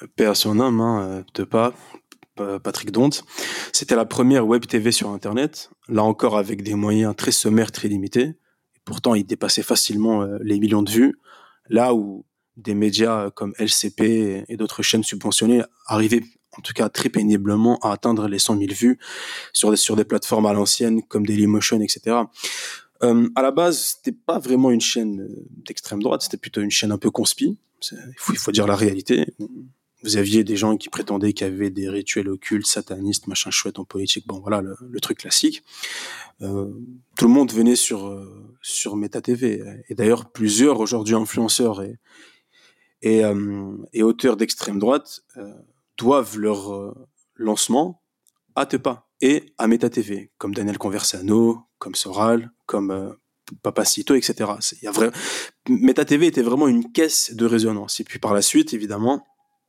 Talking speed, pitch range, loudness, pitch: 165 wpm, 105-120 Hz, -20 LUFS, 110 Hz